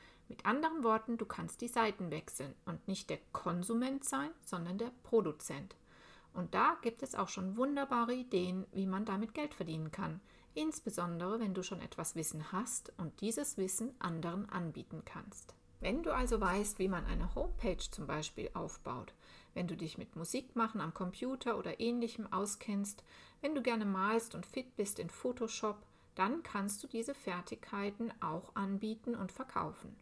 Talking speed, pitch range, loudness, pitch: 165 wpm, 185-235 Hz, -39 LUFS, 210 Hz